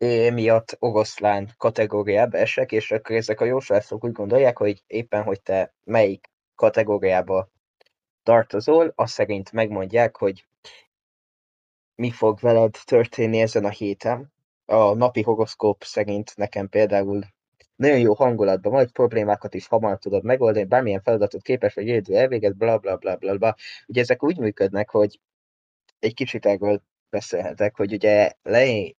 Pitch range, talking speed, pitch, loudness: 100-115 Hz, 135 wpm, 110 Hz, -21 LUFS